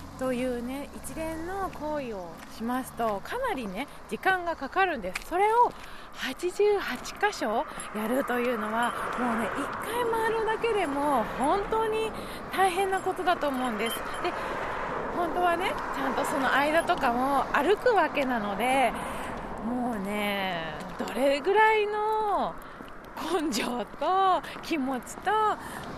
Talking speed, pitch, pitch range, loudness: 235 characters per minute, 305 Hz, 245-385 Hz, -28 LUFS